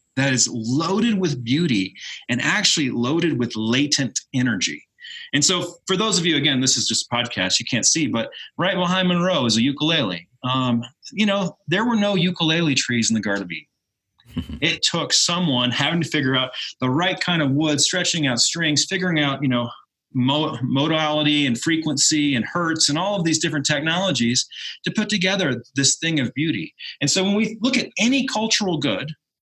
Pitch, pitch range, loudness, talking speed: 150 Hz, 130-180 Hz, -20 LUFS, 185 wpm